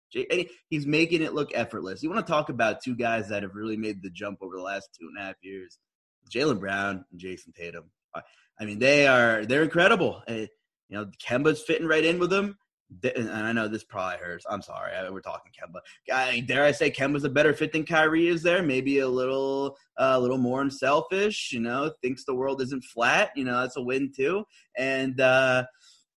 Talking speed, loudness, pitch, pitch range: 210 wpm, -26 LUFS, 130 Hz, 110-155 Hz